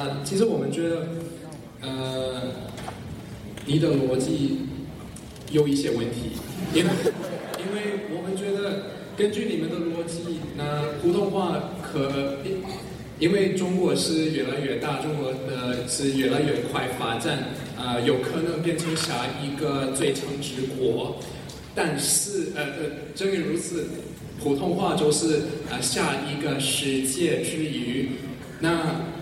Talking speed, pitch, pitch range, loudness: 195 characters per minute, 150 Hz, 135-170 Hz, -26 LUFS